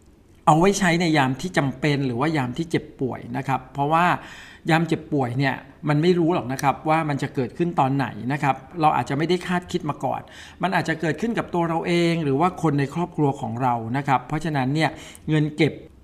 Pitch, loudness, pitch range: 150 Hz, -23 LUFS, 135-165 Hz